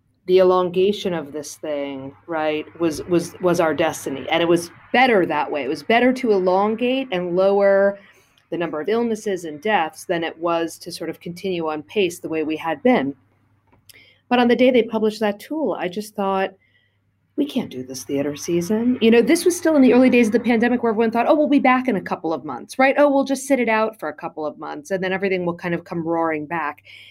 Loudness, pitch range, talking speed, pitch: -20 LUFS, 160-230 Hz, 235 wpm, 185 Hz